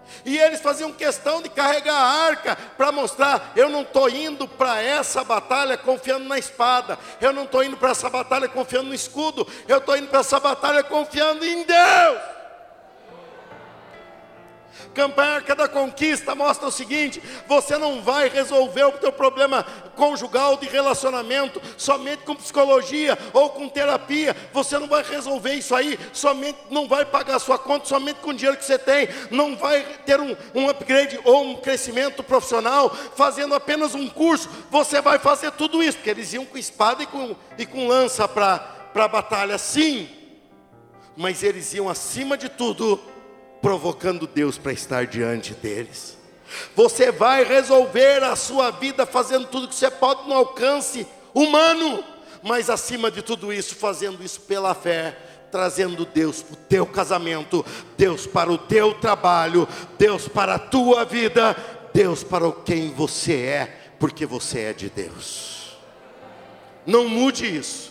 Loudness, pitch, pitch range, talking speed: -21 LUFS, 265 Hz, 215-285 Hz, 160 wpm